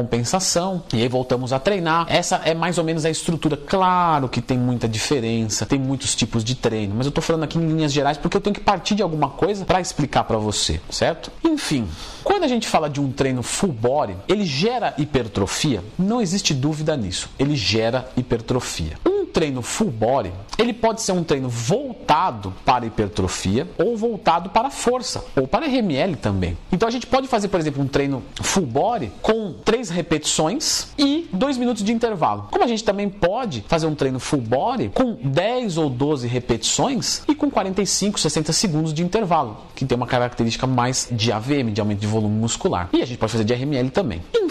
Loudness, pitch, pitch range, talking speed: -21 LUFS, 150 Hz, 120-200 Hz, 195 wpm